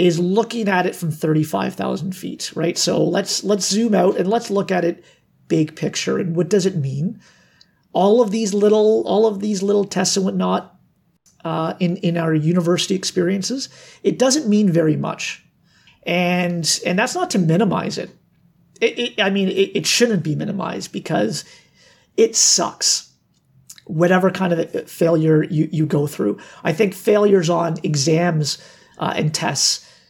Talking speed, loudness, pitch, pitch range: 165 wpm, -19 LUFS, 180 Hz, 165-205 Hz